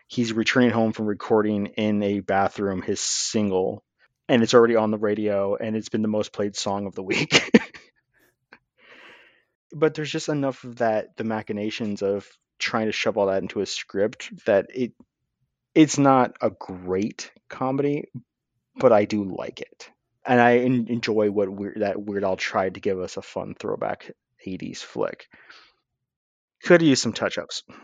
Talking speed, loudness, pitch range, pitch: 165 wpm, -23 LUFS, 100-120 Hz, 110 Hz